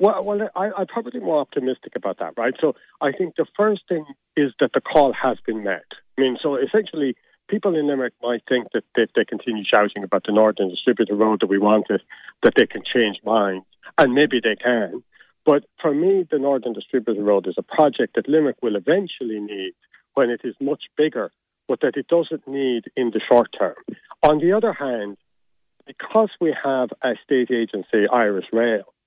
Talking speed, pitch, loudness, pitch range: 190 wpm, 130 Hz, -21 LUFS, 110-160 Hz